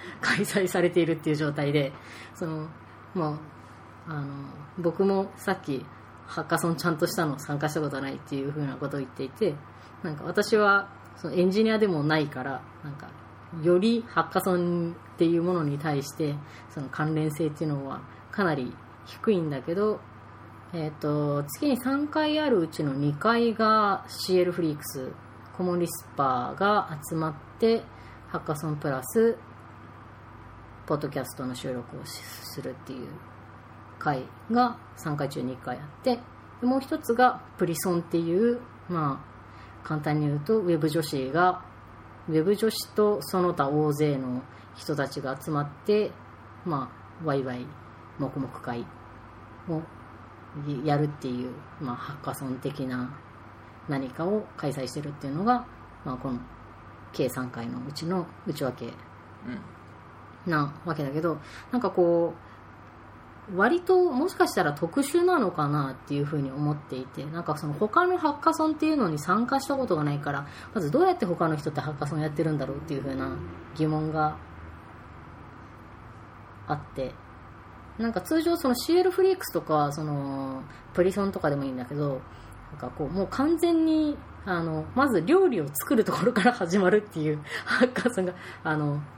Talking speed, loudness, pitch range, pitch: 305 characters per minute, -28 LUFS, 130-180 Hz, 150 Hz